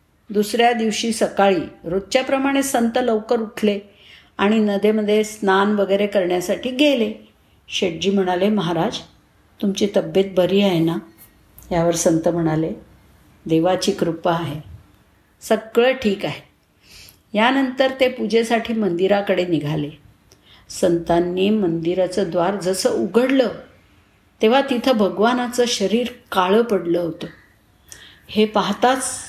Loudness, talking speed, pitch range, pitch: -19 LUFS, 100 wpm, 170-225 Hz, 200 Hz